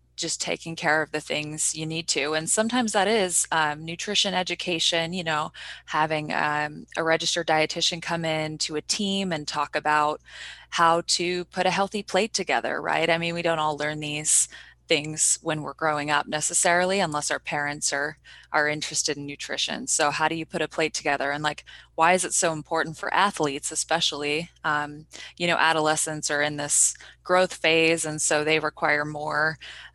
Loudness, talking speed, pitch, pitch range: -24 LUFS, 185 wpm, 155 Hz, 150-170 Hz